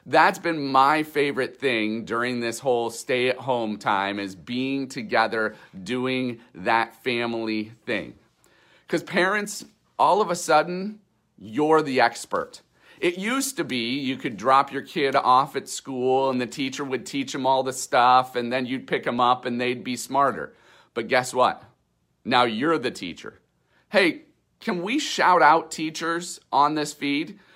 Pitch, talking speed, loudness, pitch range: 130 Hz, 165 wpm, -23 LUFS, 120-160 Hz